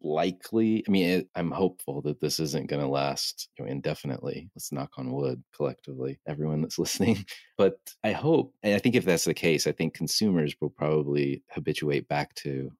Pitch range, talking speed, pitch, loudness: 70-90 Hz, 190 wpm, 75 Hz, -28 LUFS